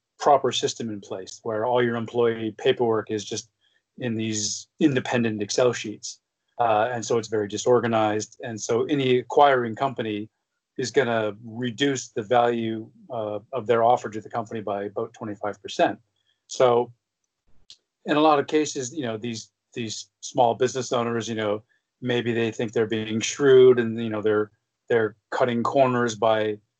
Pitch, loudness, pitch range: 115 Hz, -24 LUFS, 110-125 Hz